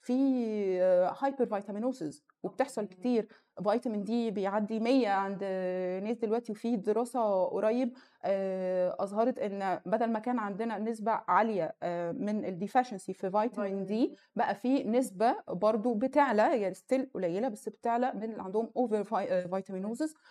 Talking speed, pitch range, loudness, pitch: 125 wpm, 195-245 Hz, -32 LUFS, 220 Hz